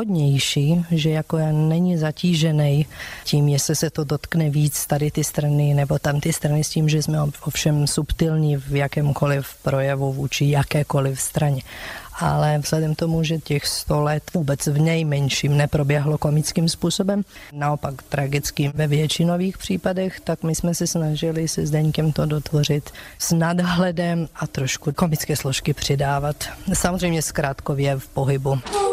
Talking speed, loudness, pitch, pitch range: 145 wpm, -21 LUFS, 150 Hz, 145-165 Hz